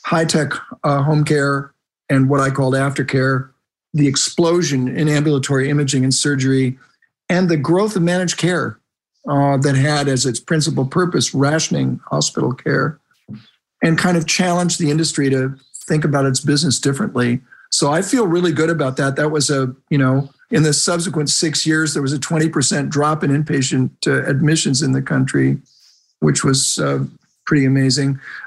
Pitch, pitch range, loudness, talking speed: 145 Hz, 135-160 Hz, -17 LUFS, 165 wpm